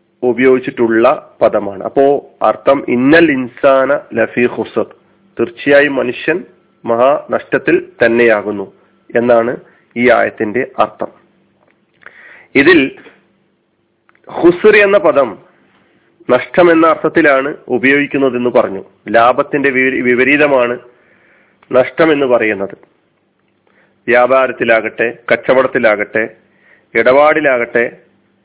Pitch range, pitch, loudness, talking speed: 120-145 Hz, 130 Hz, -12 LUFS, 70 wpm